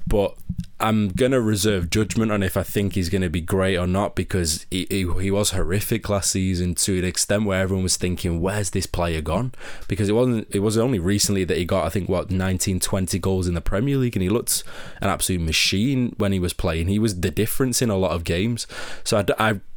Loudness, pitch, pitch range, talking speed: -22 LUFS, 95 Hz, 90-105 Hz, 230 wpm